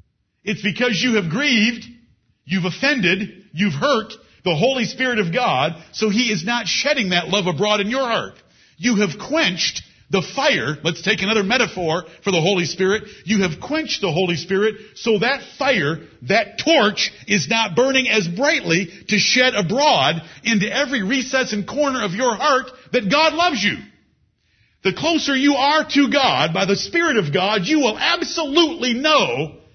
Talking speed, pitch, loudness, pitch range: 170 wpm, 215 Hz, -18 LUFS, 190-265 Hz